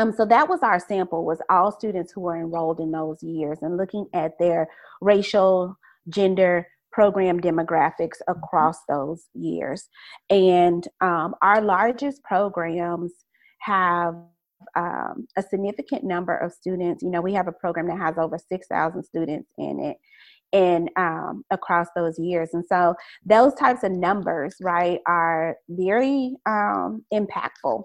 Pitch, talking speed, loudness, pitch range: 180 Hz, 145 wpm, -23 LUFS, 170-200 Hz